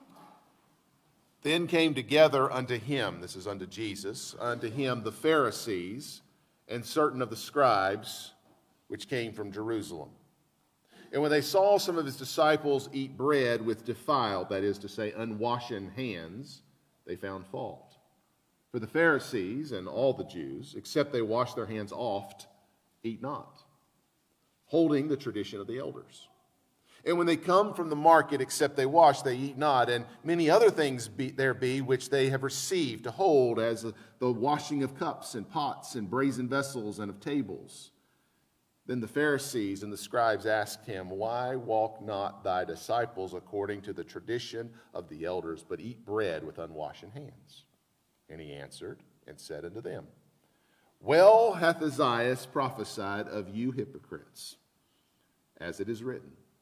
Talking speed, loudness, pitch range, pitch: 155 wpm, -30 LUFS, 110-140 Hz, 125 Hz